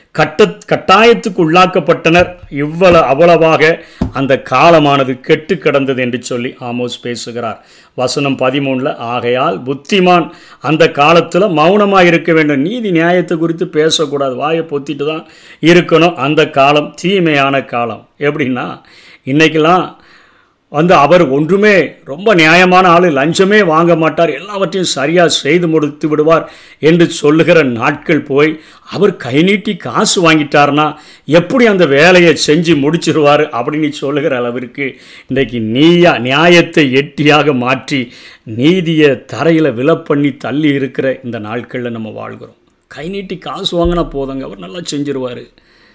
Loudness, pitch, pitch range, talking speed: -10 LUFS, 155 Hz, 135-170 Hz, 115 wpm